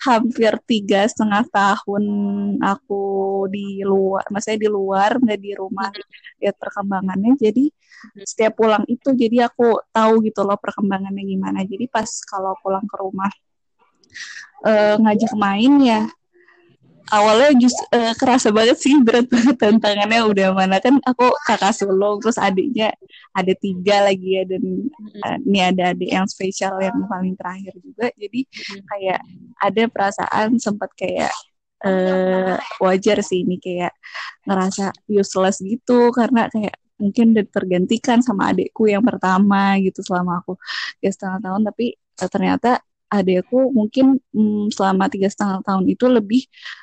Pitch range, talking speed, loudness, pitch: 195-230 Hz, 140 wpm, -18 LUFS, 205 Hz